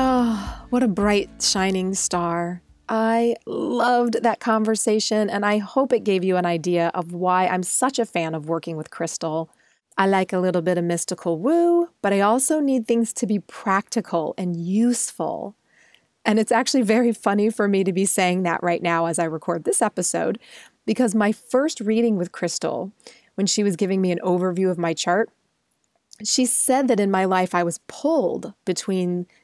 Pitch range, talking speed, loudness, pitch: 180-230 Hz, 185 wpm, -21 LUFS, 200 Hz